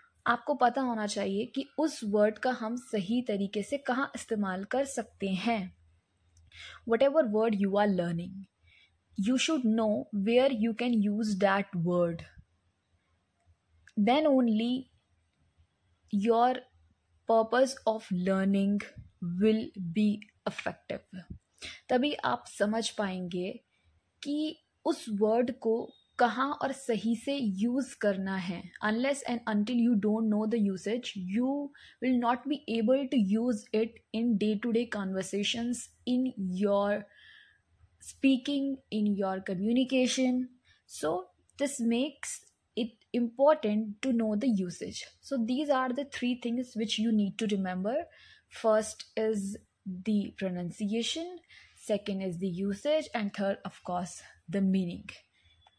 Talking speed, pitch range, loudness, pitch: 125 wpm, 195-250 Hz, -31 LUFS, 220 Hz